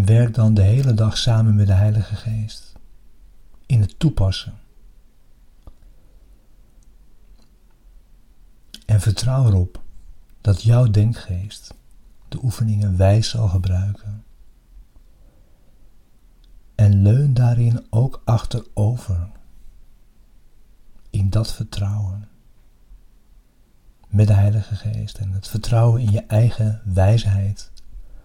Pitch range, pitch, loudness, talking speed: 100-115 Hz, 105 Hz, -19 LUFS, 95 wpm